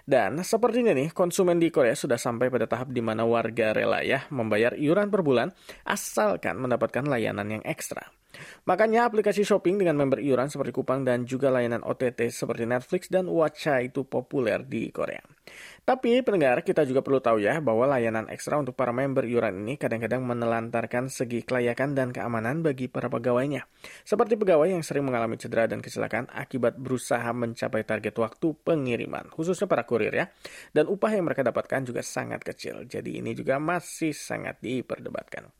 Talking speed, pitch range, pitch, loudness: 170 wpm, 115-160 Hz, 130 Hz, -27 LUFS